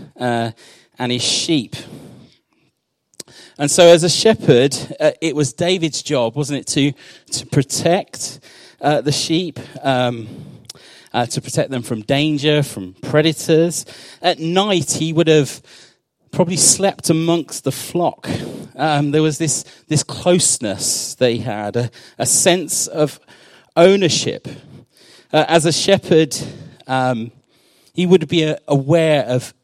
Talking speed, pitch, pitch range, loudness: 130 wpm, 150 Hz, 130-165 Hz, -16 LUFS